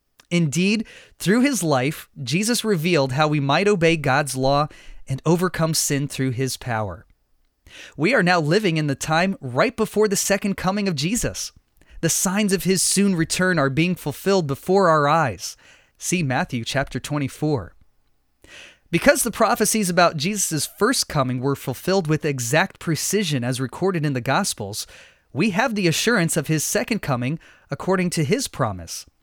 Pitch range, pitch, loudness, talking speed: 135-195 Hz, 160 Hz, -21 LUFS, 160 wpm